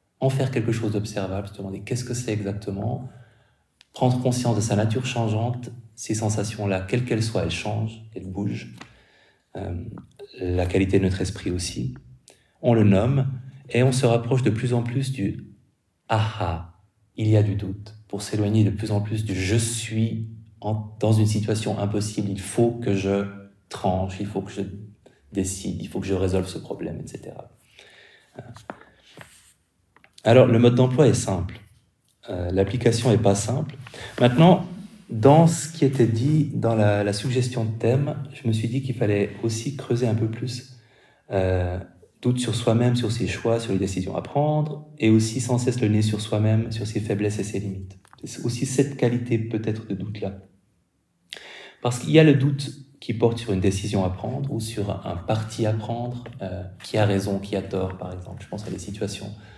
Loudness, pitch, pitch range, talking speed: -24 LUFS, 110 Hz, 100-125 Hz, 185 wpm